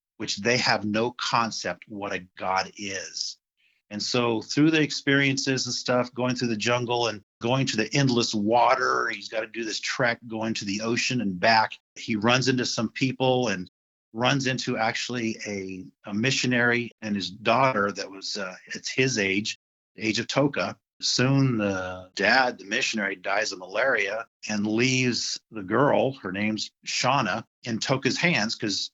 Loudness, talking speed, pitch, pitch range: -25 LUFS, 170 wpm, 115 Hz, 105-125 Hz